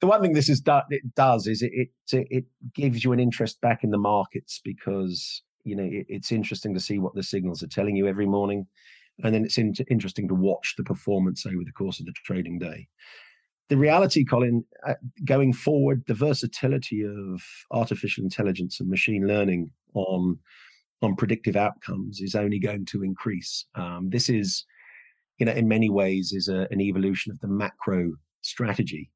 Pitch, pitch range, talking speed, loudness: 105 Hz, 95-120 Hz, 180 wpm, -26 LUFS